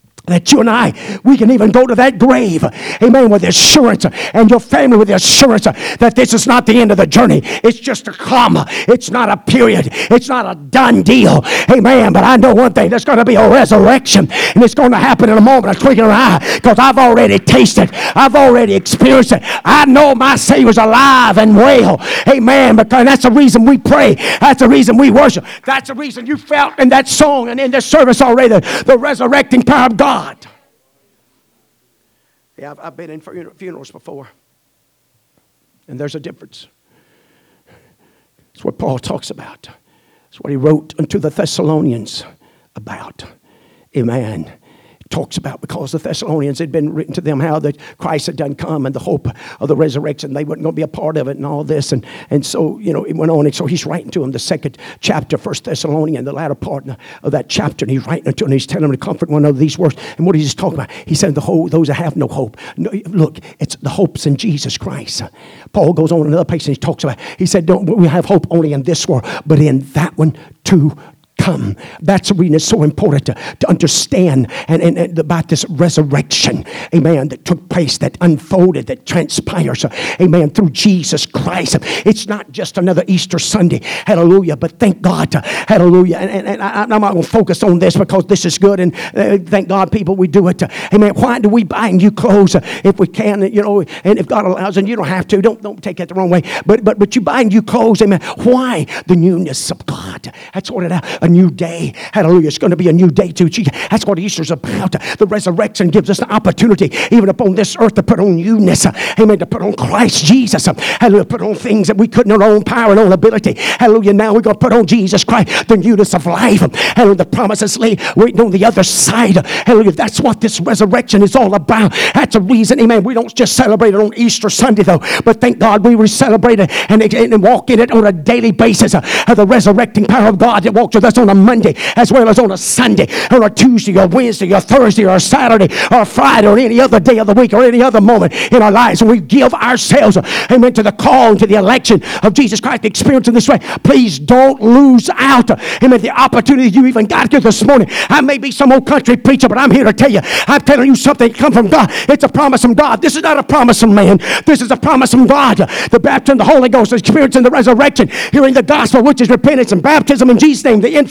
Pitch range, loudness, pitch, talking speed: 175-245 Hz, -9 LUFS, 210 Hz, 230 wpm